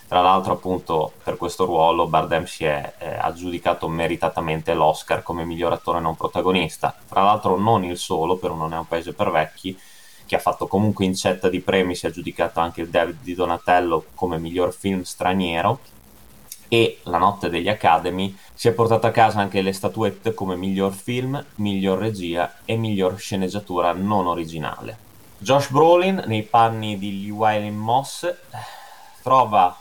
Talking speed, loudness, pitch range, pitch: 160 wpm, -21 LUFS, 90-110 Hz, 95 Hz